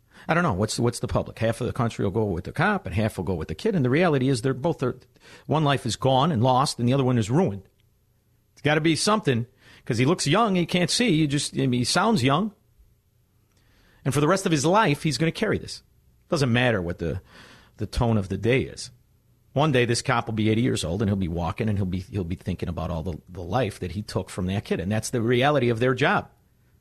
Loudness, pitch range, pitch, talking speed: -24 LUFS, 105-140 Hz, 120 Hz, 270 wpm